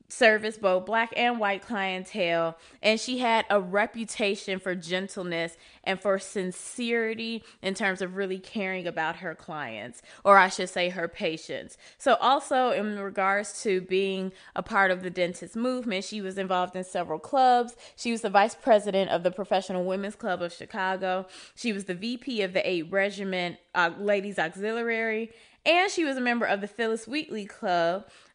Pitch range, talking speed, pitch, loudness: 185-225 Hz, 170 wpm, 195 Hz, -27 LUFS